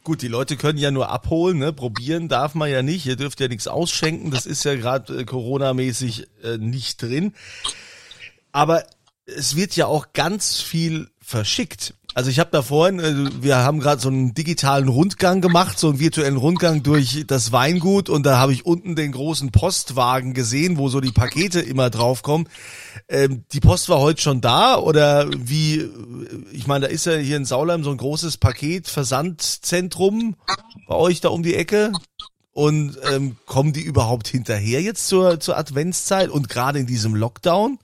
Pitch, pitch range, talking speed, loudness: 145 Hz, 130-165 Hz, 180 wpm, -20 LUFS